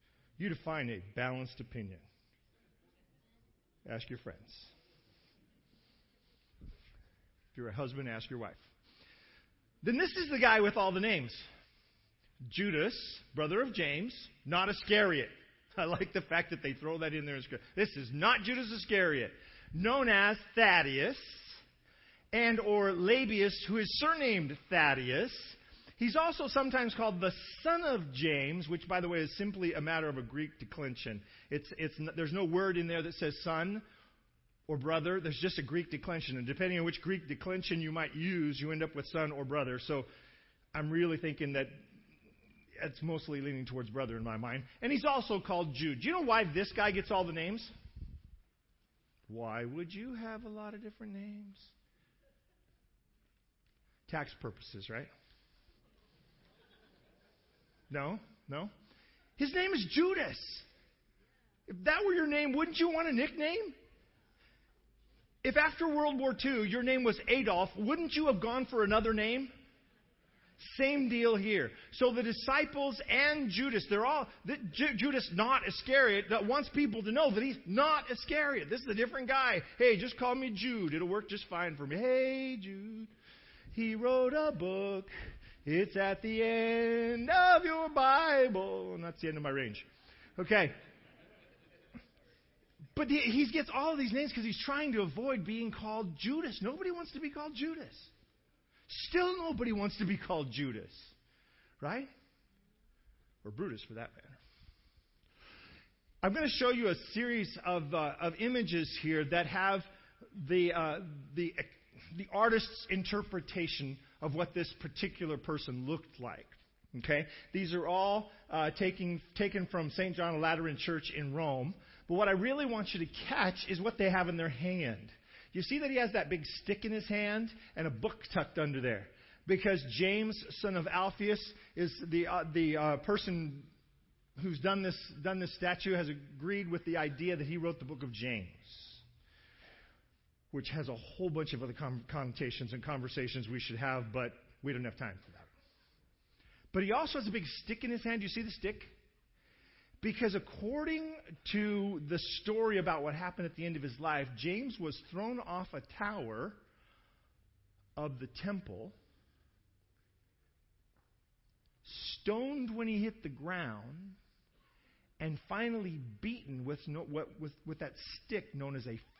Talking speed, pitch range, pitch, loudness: 160 wpm, 145-225 Hz, 180 Hz, -35 LUFS